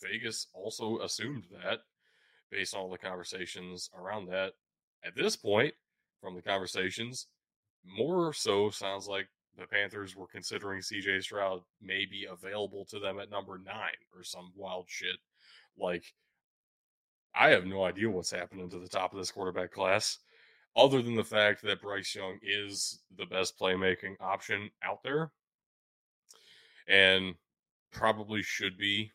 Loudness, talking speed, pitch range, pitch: -32 LUFS, 145 wpm, 95-105 Hz, 95 Hz